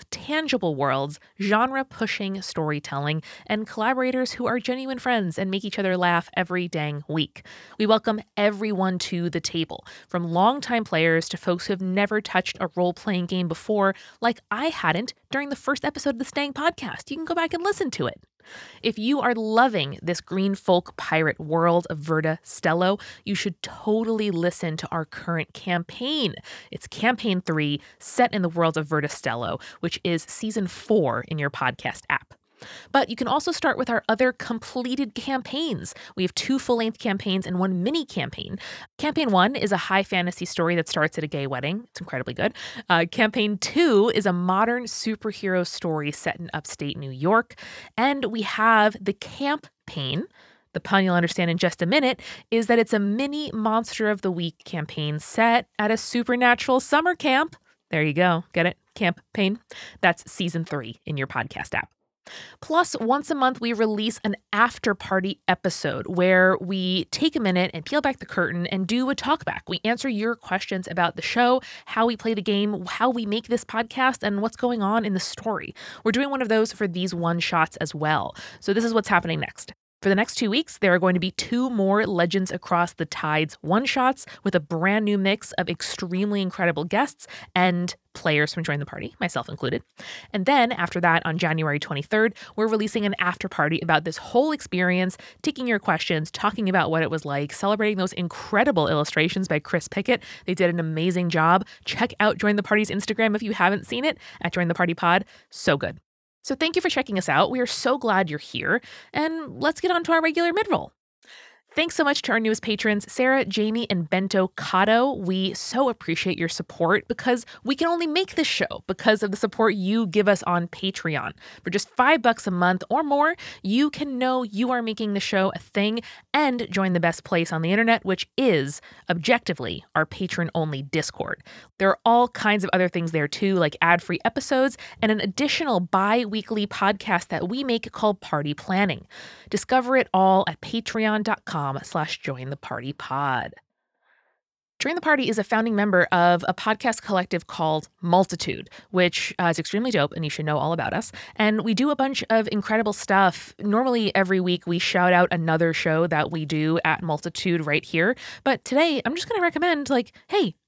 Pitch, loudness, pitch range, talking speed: 200 Hz, -24 LUFS, 175-235 Hz, 195 wpm